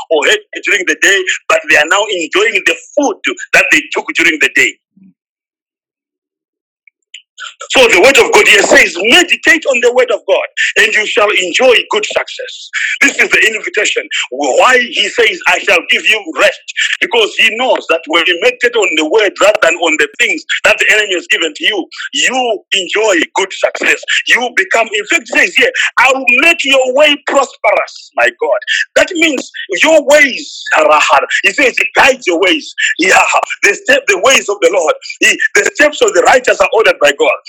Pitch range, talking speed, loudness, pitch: 285-440 Hz, 190 wpm, -9 LUFS, 340 Hz